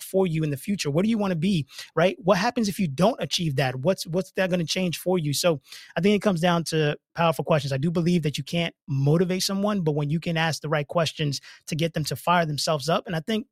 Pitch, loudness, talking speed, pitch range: 170 Hz, -25 LUFS, 275 wpm, 155-185 Hz